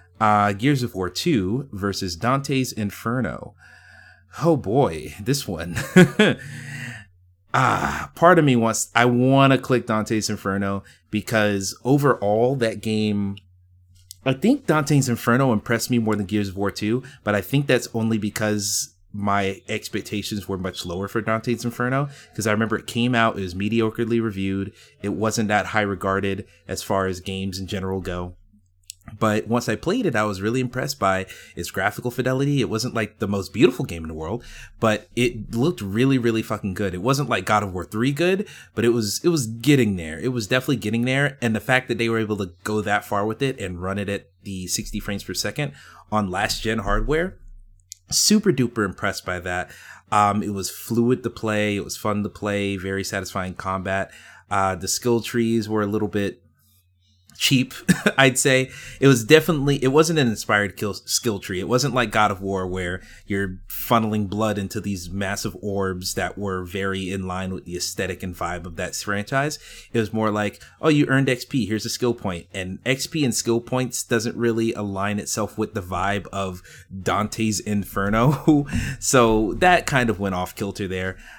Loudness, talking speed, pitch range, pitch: -22 LUFS, 185 wpm, 95-120 Hz, 105 Hz